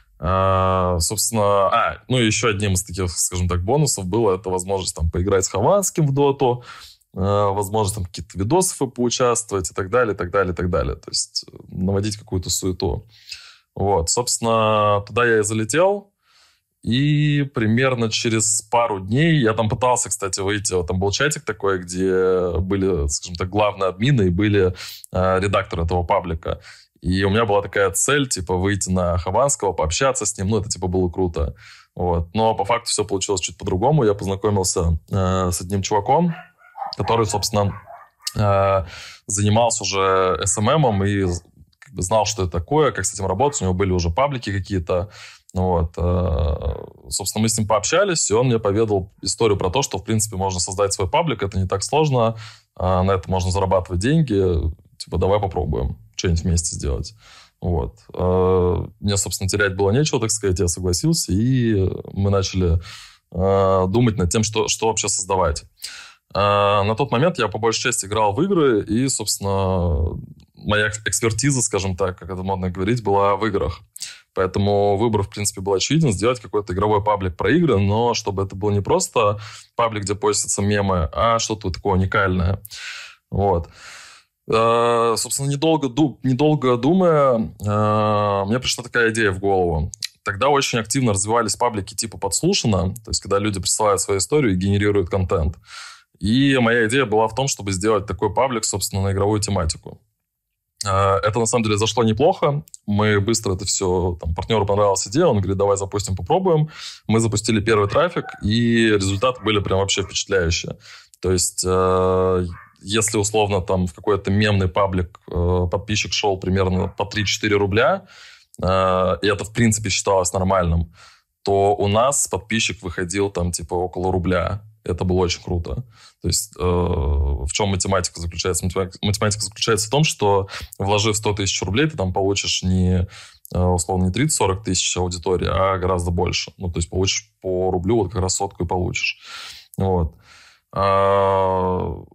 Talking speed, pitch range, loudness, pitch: 165 wpm, 95-110 Hz, -20 LUFS, 100 Hz